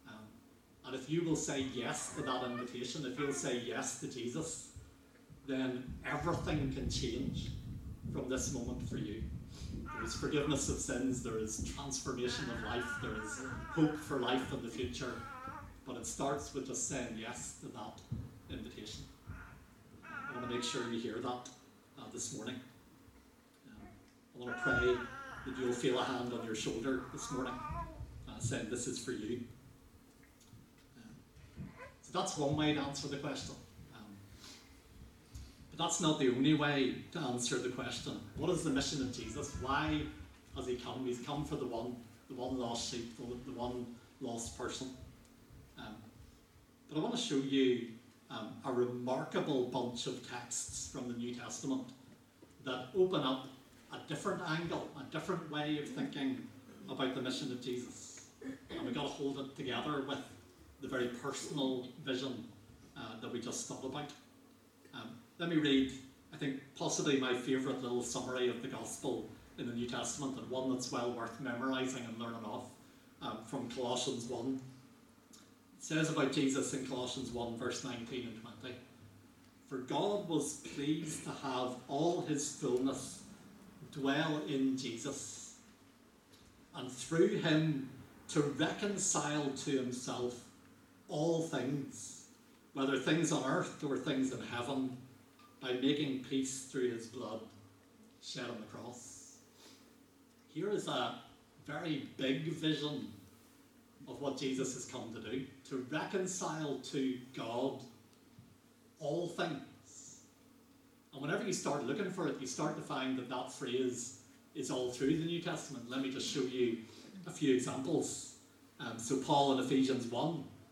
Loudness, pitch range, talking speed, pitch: -38 LUFS, 125-145 Hz, 155 wpm, 130 Hz